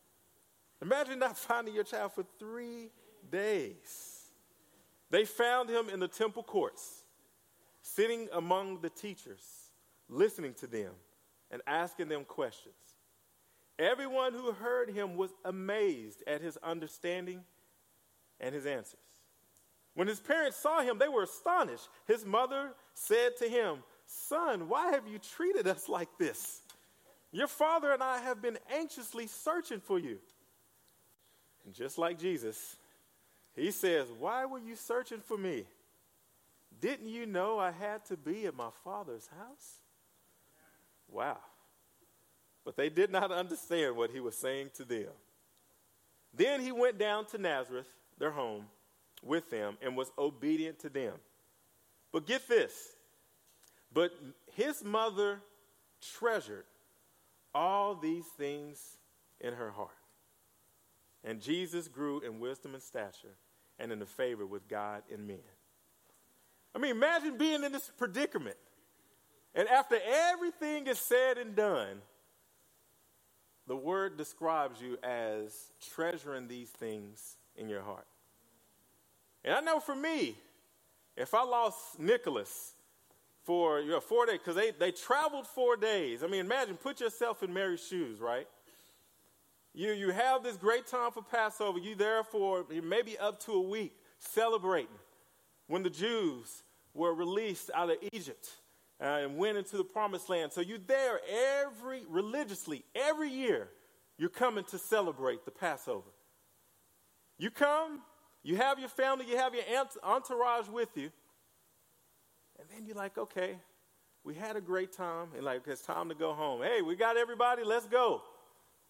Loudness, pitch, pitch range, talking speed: -35 LUFS, 215 Hz, 160-265 Hz, 140 wpm